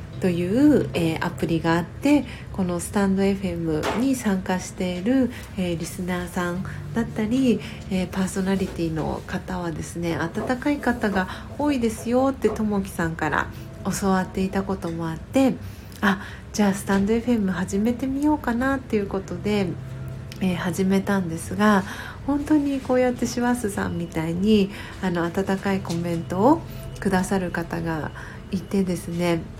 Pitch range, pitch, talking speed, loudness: 175-225 Hz, 195 Hz, 320 characters per minute, -24 LUFS